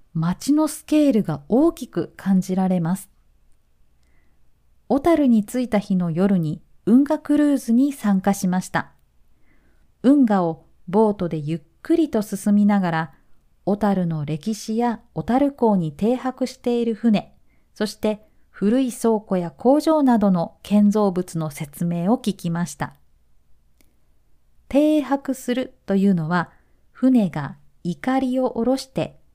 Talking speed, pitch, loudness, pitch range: 235 characters per minute, 205 Hz, -21 LUFS, 165-250 Hz